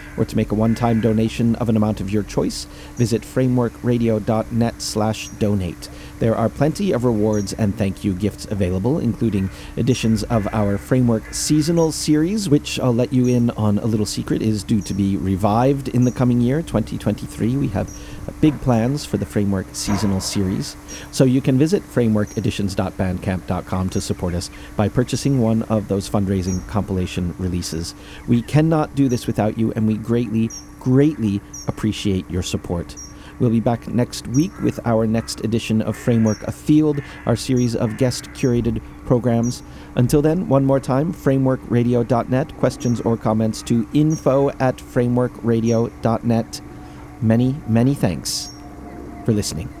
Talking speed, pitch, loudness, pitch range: 155 wpm, 115 Hz, -20 LUFS, 100-125 Hz